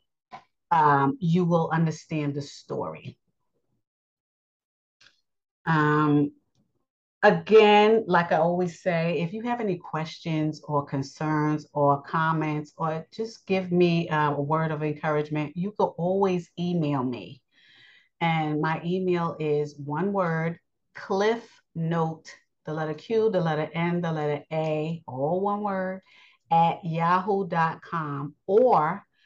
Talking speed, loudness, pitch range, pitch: 115 wpm, -25 LUFS, 150-180 Hz, 165 Hz